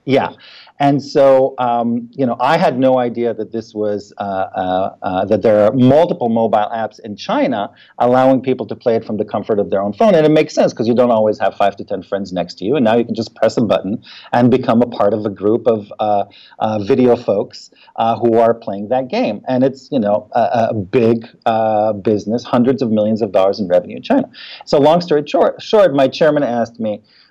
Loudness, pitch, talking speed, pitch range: -15 LUFS, 115 Hz, 230 wpm, 105-130 Hz